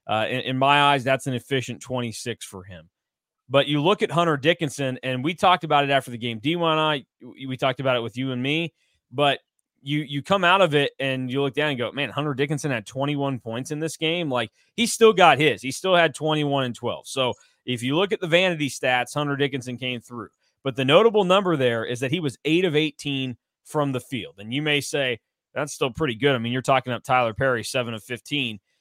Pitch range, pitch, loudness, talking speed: 125-150 Hz, 140 Hz, -23 LUFS, 235 wpm